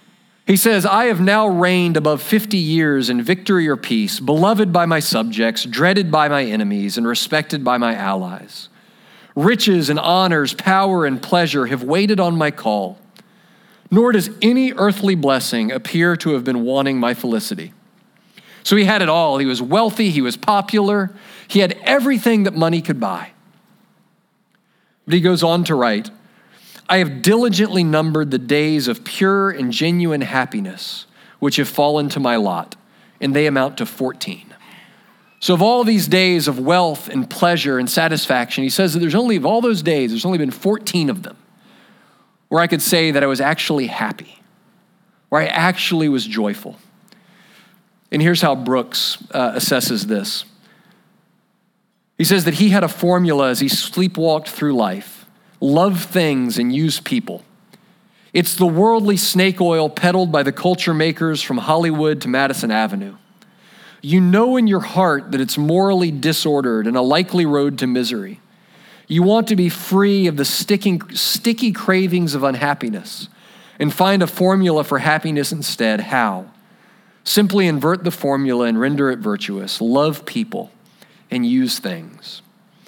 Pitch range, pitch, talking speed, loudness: 150-205 Hz, 185 Hz, 160 wpm, -17 LUFS